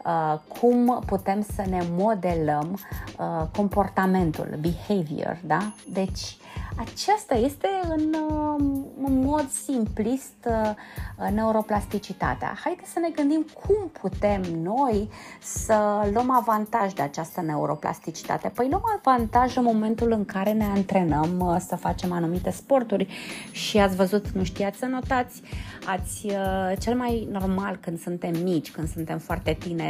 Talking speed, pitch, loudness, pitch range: 135 wpm, 205 Hz, -26 LUFS, 185-245 Hz